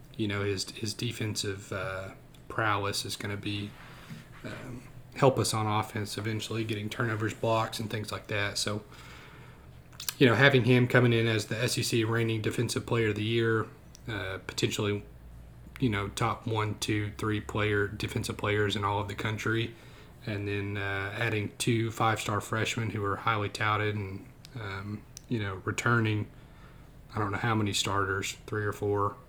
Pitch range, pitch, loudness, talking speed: 100-115 Hz, 110 Hz, -30 LUFS, 170 wpm